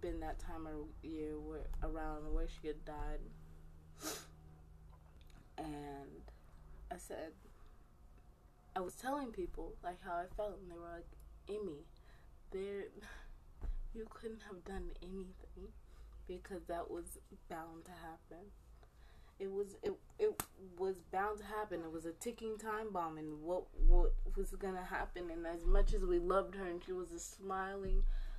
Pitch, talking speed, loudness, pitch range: 175 Hz, 150 wpm, -44 LUFS, 150-195 Hz